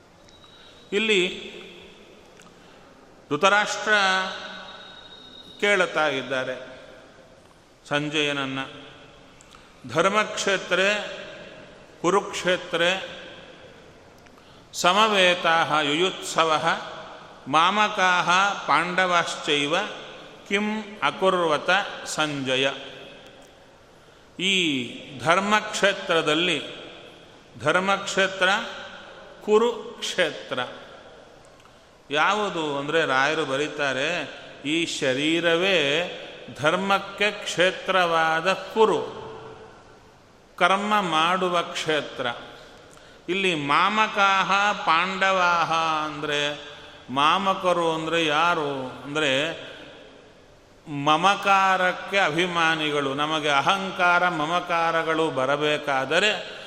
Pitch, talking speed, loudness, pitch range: 175 Hz, 45 wpm, -22 LUFS, 150-195 Hz